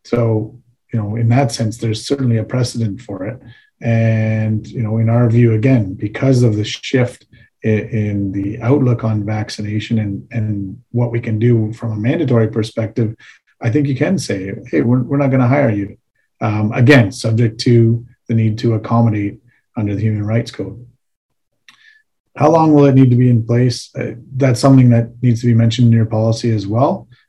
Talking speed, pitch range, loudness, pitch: 190 wpm, 110-125 Hz, -15 LUFS, 115 Hz